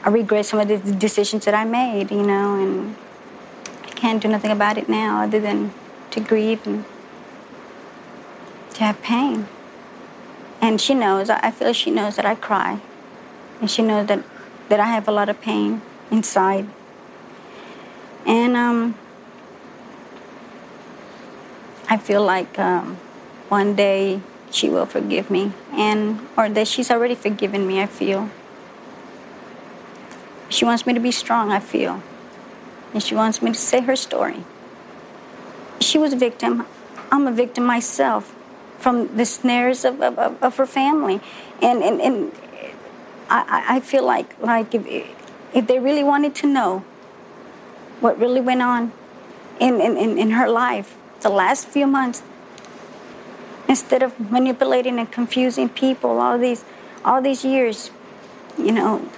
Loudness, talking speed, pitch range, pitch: -19 LUFS, 145 wpm, 205-250 Hz, 225 Hz